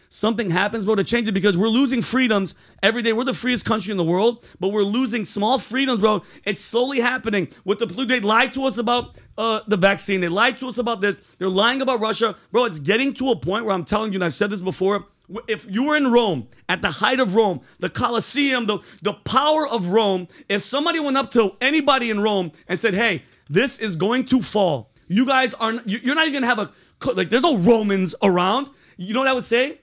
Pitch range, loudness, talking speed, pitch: 200-245 Hz, -20 LUFS, 235 wpm, 220 Hz